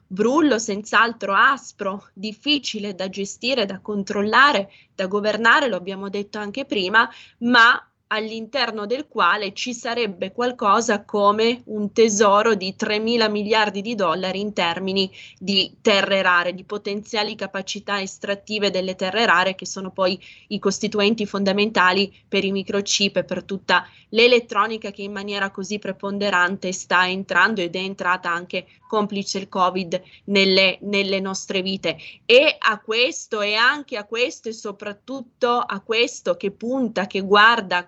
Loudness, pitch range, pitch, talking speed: -20 LUFS, 195-225 Hz, 205 Hz, 140 wpm